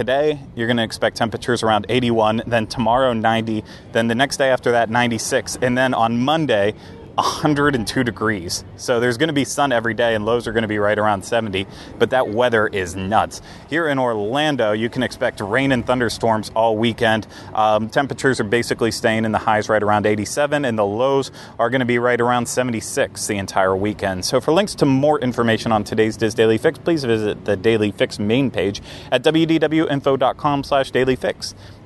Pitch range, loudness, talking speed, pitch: 110-130 Hz, -19 LUFS, 195 wpm, 115 Hz